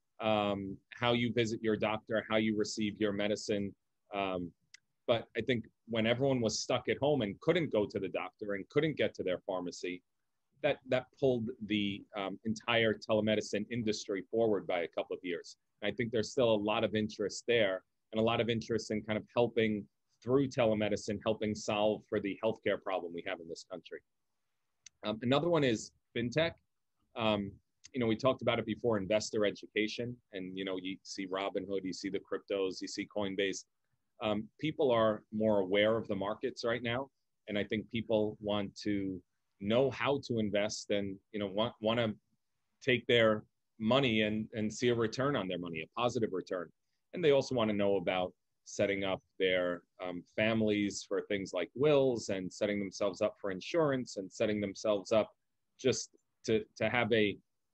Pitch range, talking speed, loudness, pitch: 100-115 Hz, 185 wpm, -34 LUFS, 110 Hz